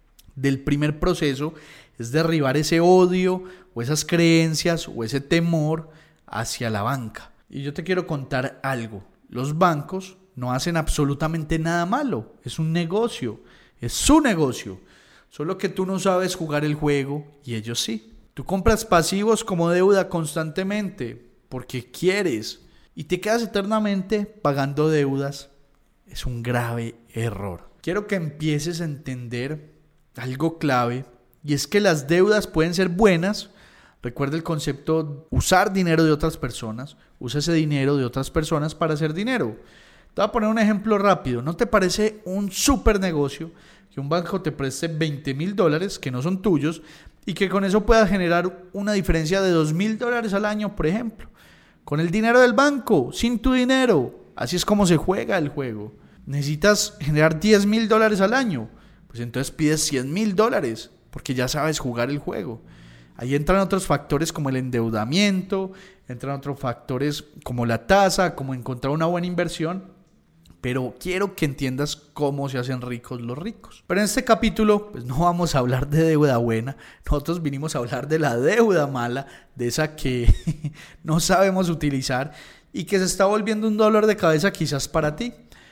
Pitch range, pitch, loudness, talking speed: 135-190 Hz, 160 Hz, -22 LUFS, 165 wpm